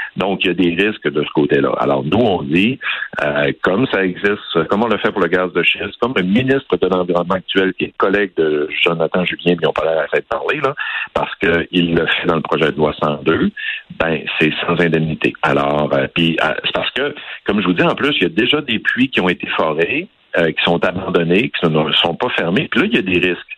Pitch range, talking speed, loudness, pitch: 80-90 Hz, 255 wpm, -16 LUFS, 85 Hz